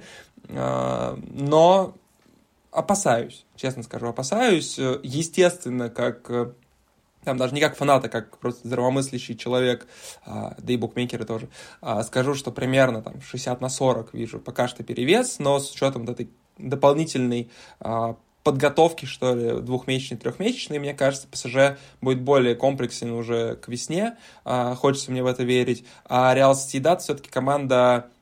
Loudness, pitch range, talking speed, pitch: -23 LUFS, 120-140 Hz, 130 wpm, 130 Hz